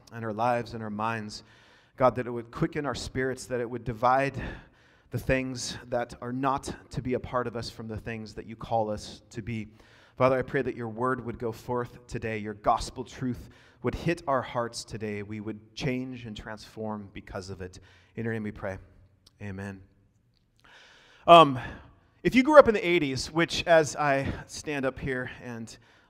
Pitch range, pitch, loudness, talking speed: 110-130 Hz, 120 Hz, -28 LUFS, 195 wpm